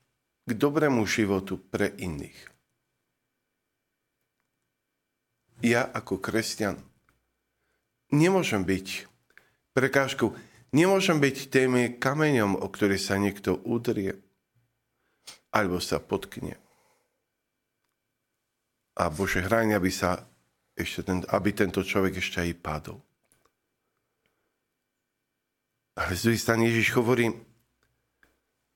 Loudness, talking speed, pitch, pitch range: -27 LUFS, 85 wpm, 110 Hz, 95-120 Hz